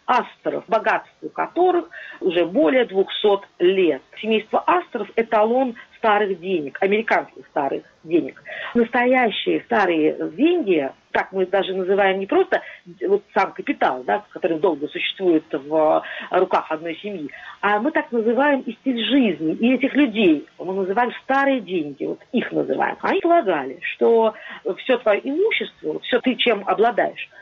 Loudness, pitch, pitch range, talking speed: -20 LUFS, 230 Hz, 195-290 Hz, 135 wpm